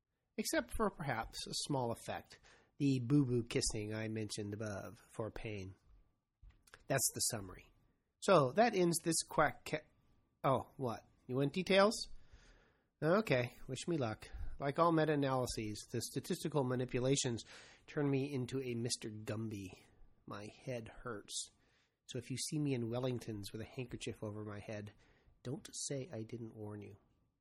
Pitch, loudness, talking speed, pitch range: 120 Hz, -38 LUFS, 150 wpm, 110-140 Hz